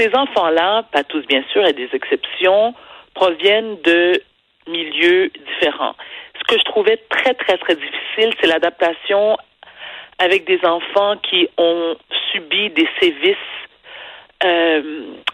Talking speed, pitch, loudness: 135 wpm, 205 Hz, -16 LUFS